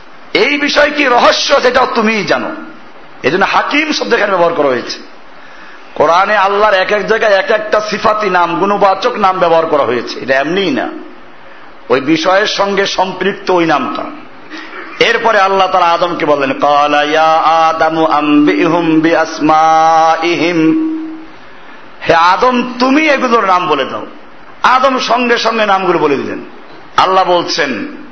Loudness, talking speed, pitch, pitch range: -11 LUFS, 130 wpm, 195 Hz, 165-250 Hz